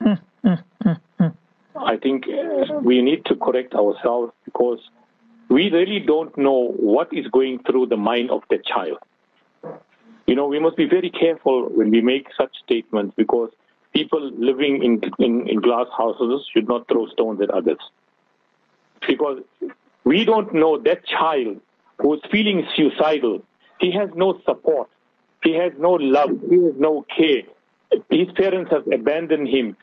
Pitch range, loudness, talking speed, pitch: 135-210 Hz, -20 LUFS, 150 wpm, 165 Hz